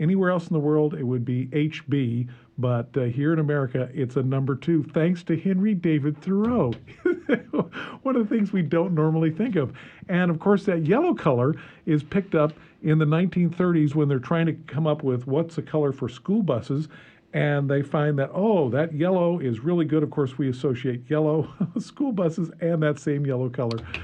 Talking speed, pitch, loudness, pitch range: 195 wpm, 155 Hz, -24 LUFS, 140-175 Hz